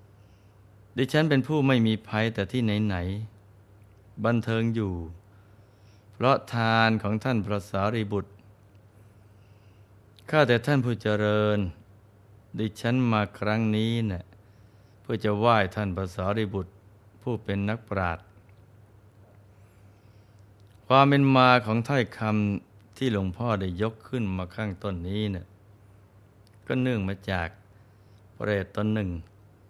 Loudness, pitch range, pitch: -26 LUFS, 100-110 Hz, 105 Hz